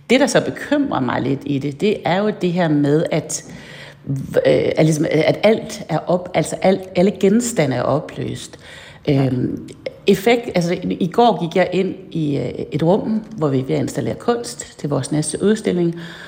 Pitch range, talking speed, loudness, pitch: 155-210 Hz, 160 wpm, -18 LUFS, 175 Hz